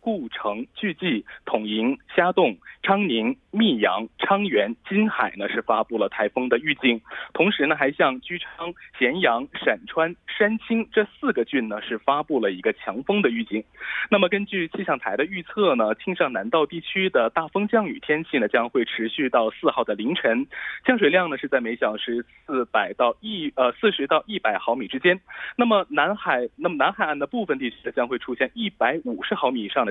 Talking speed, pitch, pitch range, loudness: 285 characters per minute, 190 Hz, 140-215 Hz, -23 LUFS